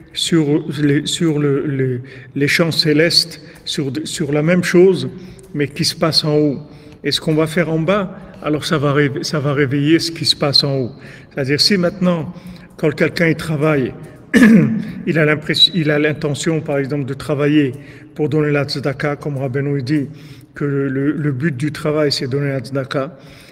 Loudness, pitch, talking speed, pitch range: -16 LUFS, 150 Hz, 190 wpm, 145-165 Hz